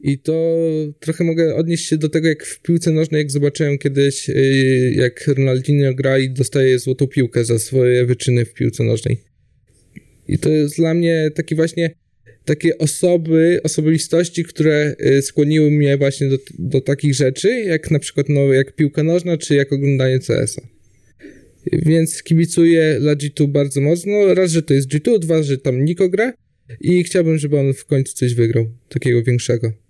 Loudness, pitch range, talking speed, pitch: -16 LUFS, 130-160 Hz, 170 wpm, 145 Hz